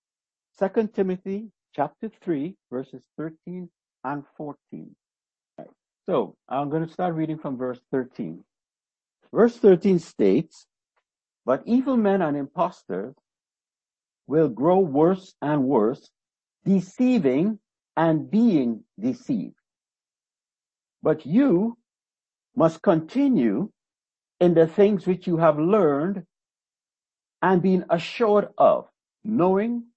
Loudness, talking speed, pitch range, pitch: -23 LUFS, 100 wpm, 160-220 Hz, 185 Hz